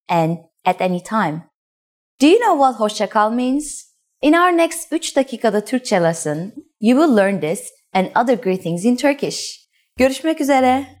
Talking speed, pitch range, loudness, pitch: 155 wpm, 185-285 Hz, -17 LUFS, 245 Hz